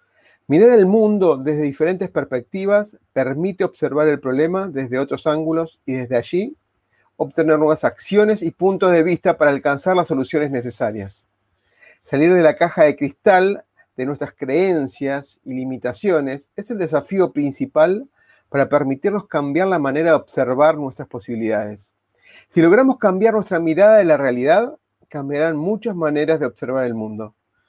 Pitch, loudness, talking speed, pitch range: 155 Hz, -18 LUFS, 145 wpm, 135-185 Hz